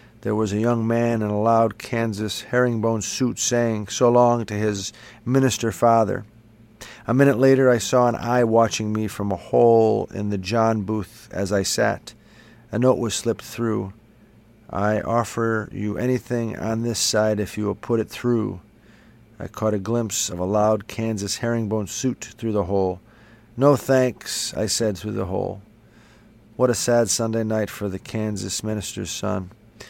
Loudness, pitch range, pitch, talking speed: -22 LUFS, 105-115 Hz, 110 Hz, 170 wpm